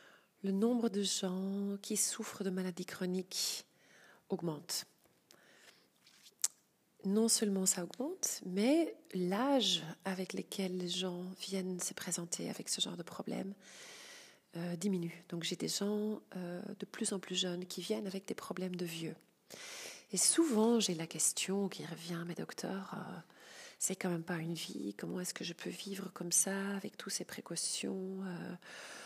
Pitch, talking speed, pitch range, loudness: 190 Hz, 160 wpm, 180-205 Hz, -37 LUFS